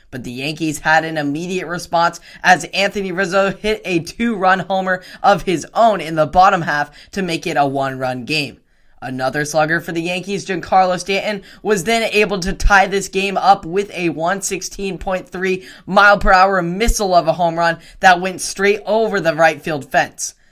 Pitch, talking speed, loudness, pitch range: 185 Hz, 180 wpm, -16 LUFS, 165-195 Hz